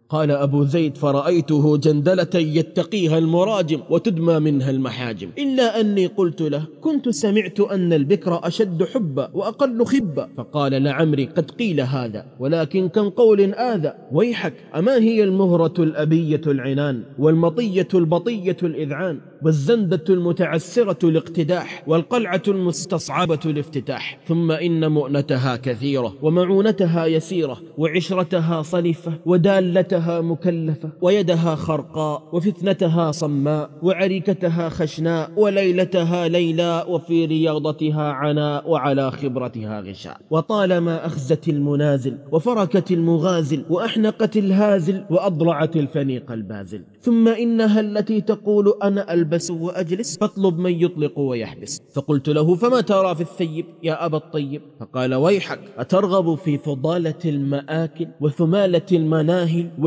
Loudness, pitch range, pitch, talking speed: -20 LUFS, 150-190 Hz, 165 Hz, 110 wpm